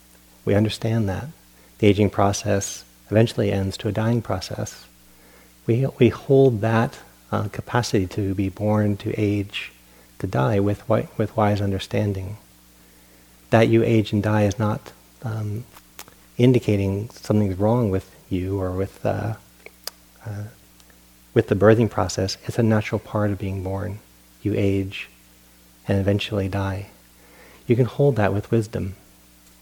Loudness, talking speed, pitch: -22 LUFS, 140 wpm, 100 Hz